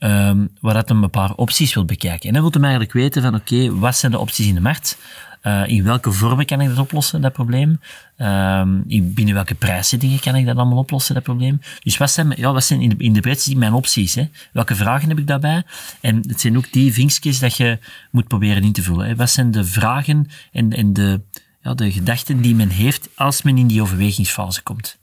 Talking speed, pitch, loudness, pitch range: 230 wpm, 120 Hz, -17 LUFS, 105-135 Hz